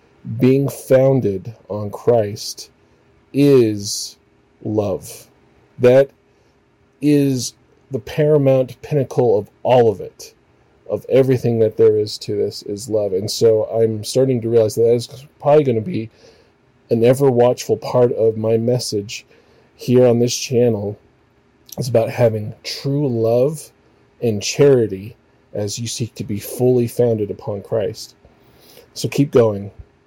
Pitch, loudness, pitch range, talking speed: 120 Hz, -17 LUFS, 110-135 Hz, 135 wpm